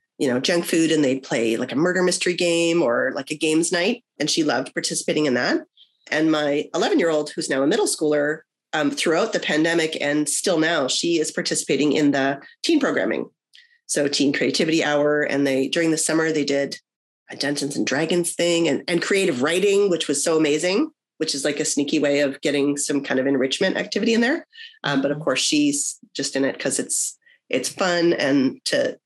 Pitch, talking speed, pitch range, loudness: 160 Hz, 205 wpm, 145-195 Hz, -21 LUFS